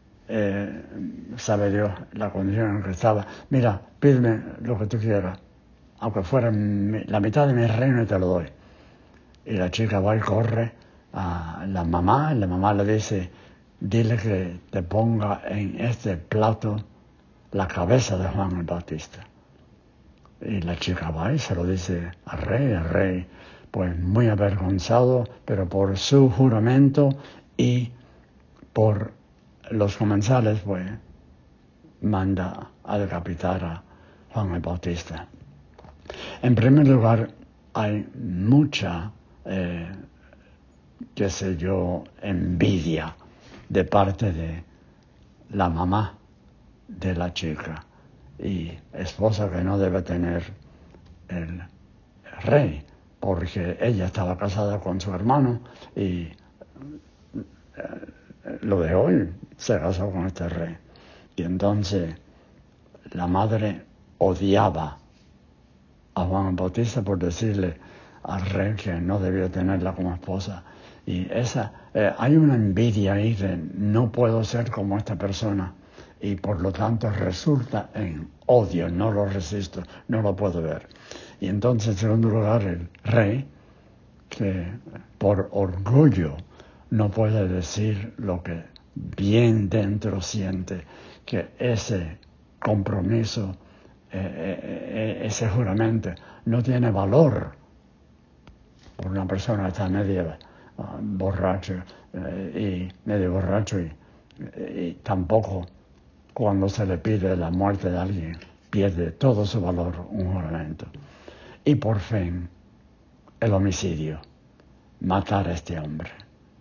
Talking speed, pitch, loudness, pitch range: 120 wpm, 95 Hz, -24 LUFS, 90-110 Hz